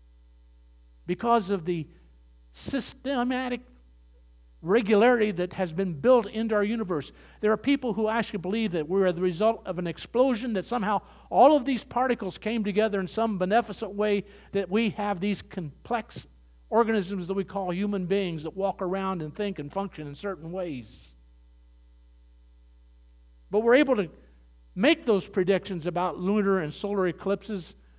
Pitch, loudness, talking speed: 195 Hz, -27 LUFS, 150 wpm